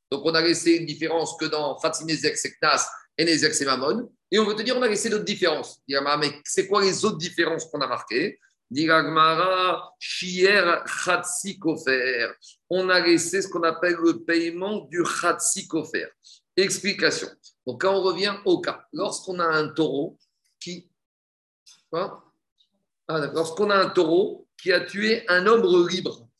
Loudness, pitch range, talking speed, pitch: -23 LUFS, 160-195 Hz, 150 wpm, 175 Hz